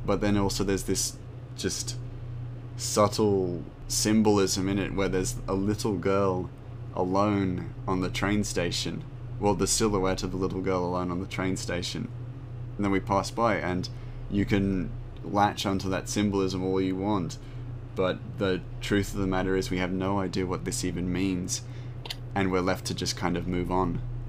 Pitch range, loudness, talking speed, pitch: 95-120 Hz, -28 LUFS, 175 wpm, 100 Hz